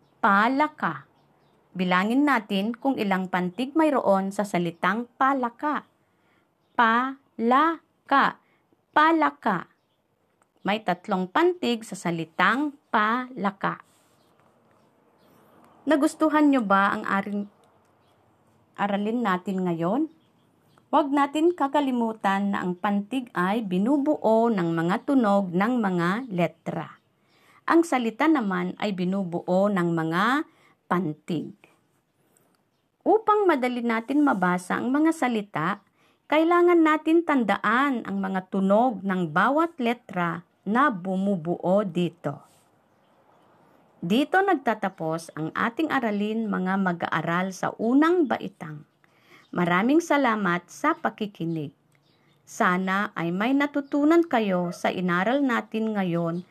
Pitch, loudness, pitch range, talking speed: 205 Hz, -24 LUFS, 180-275 Hz, 95 wpm